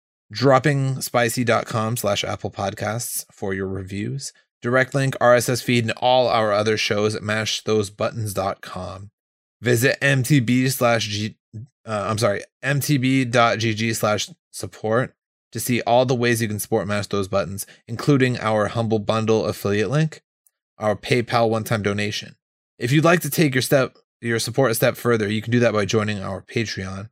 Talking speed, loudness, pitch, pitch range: 155 wpm, -21 LUFS, 115 Hz, 105-130 Hz